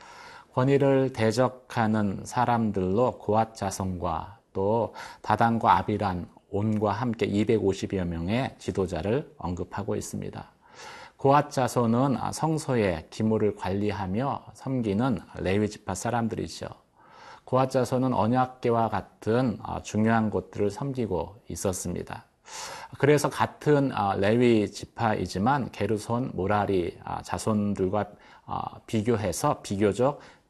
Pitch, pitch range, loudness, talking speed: 110 Hz, 100-125 Hz, -27 LUFS, 240 characters per minute